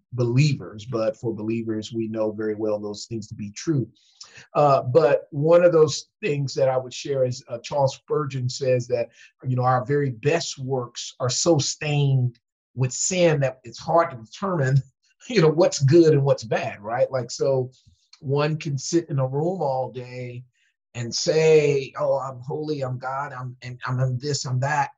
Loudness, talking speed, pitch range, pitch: -23 LUFS, 185 wpm, 125-150 Hz, 130 Hz